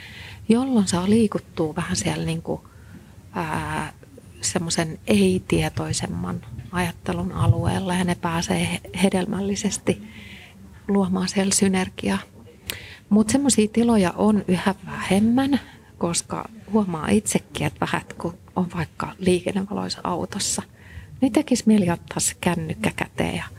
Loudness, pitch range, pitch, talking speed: -23 LUFS, 165-210 Hz, 185 Hz, 100 wpm